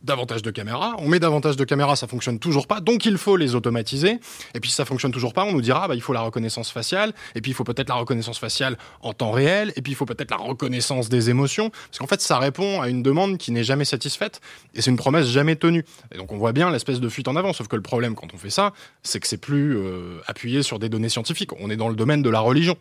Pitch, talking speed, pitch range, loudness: 130 Hz, 280 wpm, 120-150 Hz, -22 LUFS